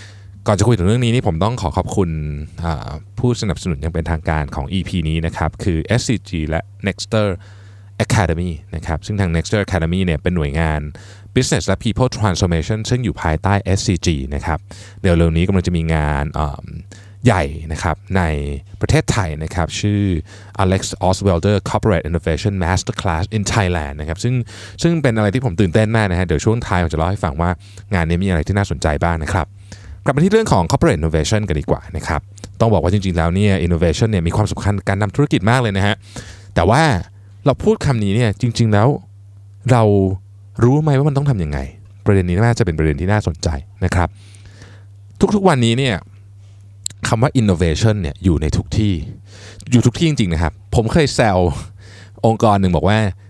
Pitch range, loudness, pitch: 85-110 Hz, -17 LUFS, 100 Hz